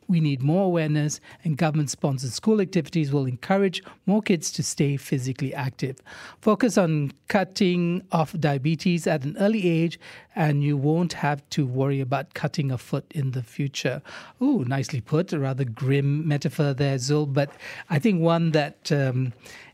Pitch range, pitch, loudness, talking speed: 140-175 Hz, 150 Hz, -24 LUFS, 165 wpm